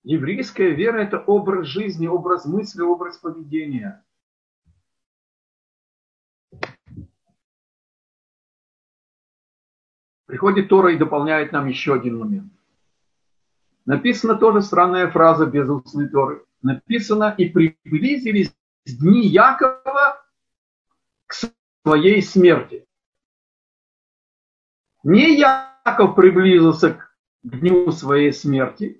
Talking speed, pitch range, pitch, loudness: 80 wpm, 155-215 Hz, 180 Hz, -17 LUFS